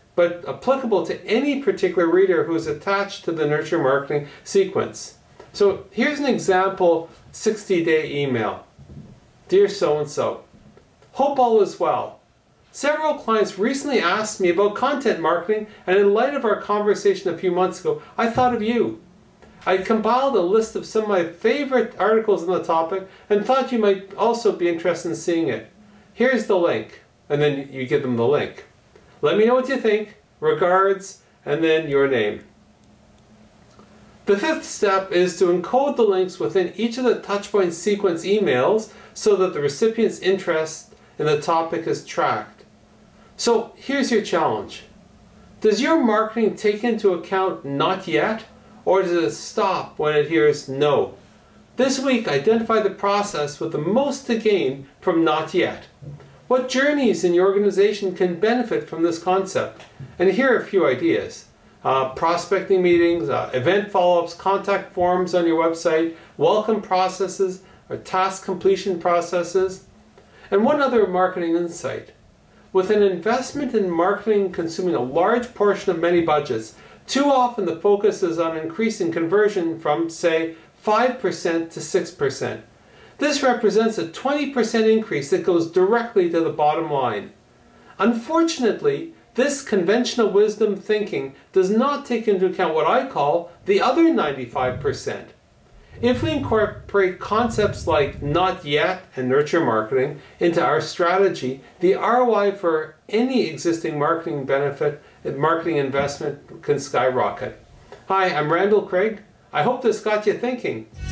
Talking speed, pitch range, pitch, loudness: 150 wpm, 165-225 Hz, 195 Hz, -21 LUFS